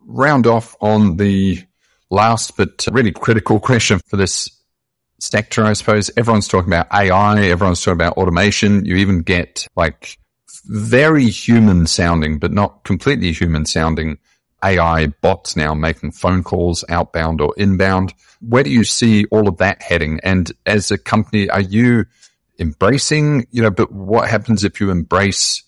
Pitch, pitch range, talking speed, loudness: 100 Hz, 85-110 Hz, 155 wpm, -15 LUFS